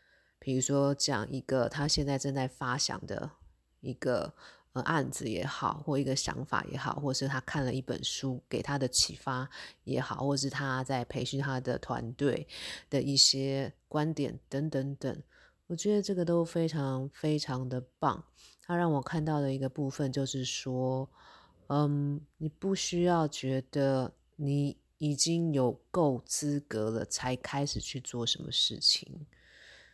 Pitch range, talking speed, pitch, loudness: 130-150 Hz, 225 characters per minute, 140 Hz, -32 LUFS